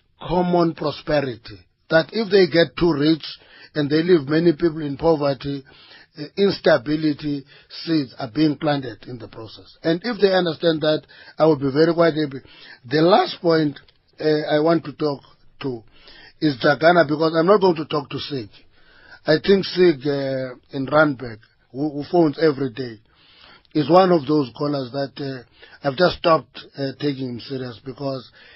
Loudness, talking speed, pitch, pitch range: -20 LUFS, 165 wpm, 150 Hz, 135-165 Hz